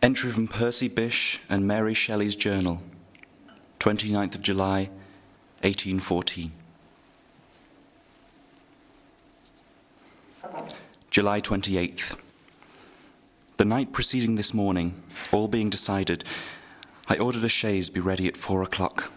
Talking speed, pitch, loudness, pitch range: 95 wpm, 100 Hz, -26 LUFS, 95-110 Hz